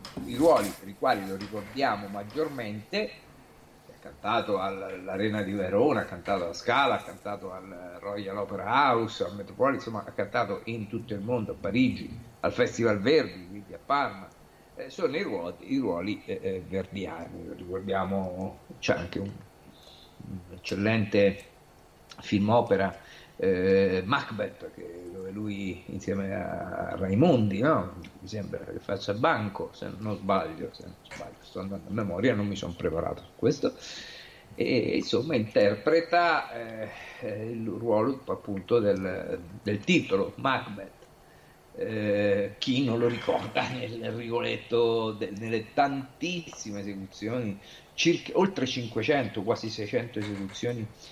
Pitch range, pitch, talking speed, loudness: 95-115 Hz, 105 Hz, 130 wpm, -29 LUFS